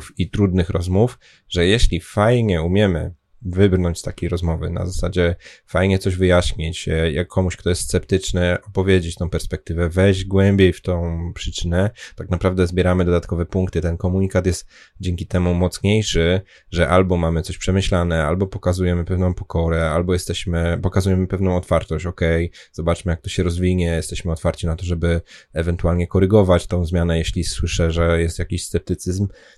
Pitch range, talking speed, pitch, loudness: 85-95 Hz, 150 wpm, 90 Hz, -20 LUFS